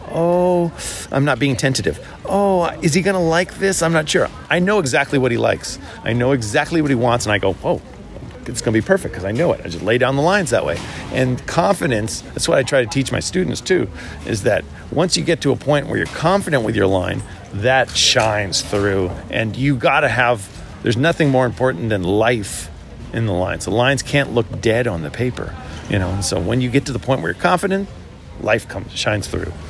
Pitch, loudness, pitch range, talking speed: 125 Hz, -18 LUFS, 100-155 Hz, 225 wpm